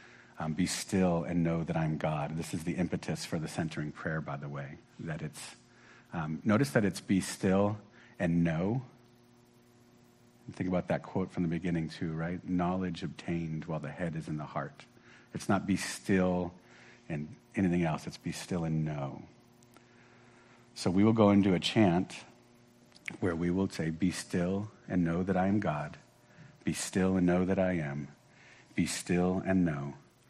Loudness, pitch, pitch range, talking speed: -32 LUFS, 90 Hz, 85-100 Hz, 180 wpm